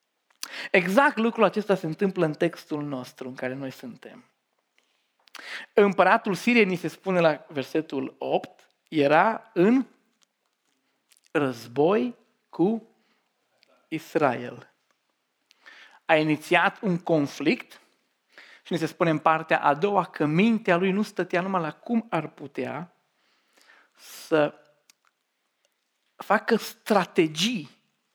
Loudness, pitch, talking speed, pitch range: -25 LUFS, 175 Hz, 105 wpm, 155-210 Hz